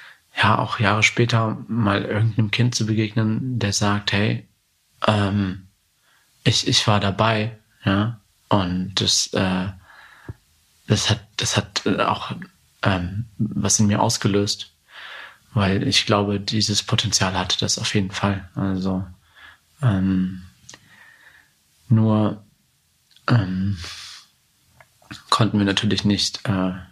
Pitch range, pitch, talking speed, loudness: 95-110 Hz, 100 Hz, 110 wpm, -21 LUFS